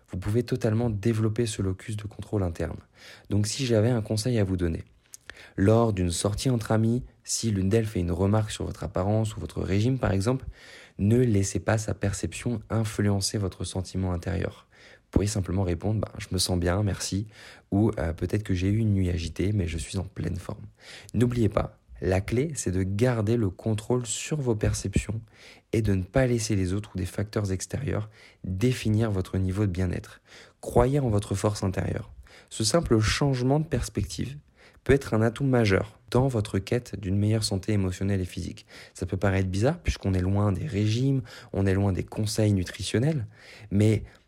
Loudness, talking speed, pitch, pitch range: -27 LUFS, 185 wpm, 105 Hz, 95-115 Hz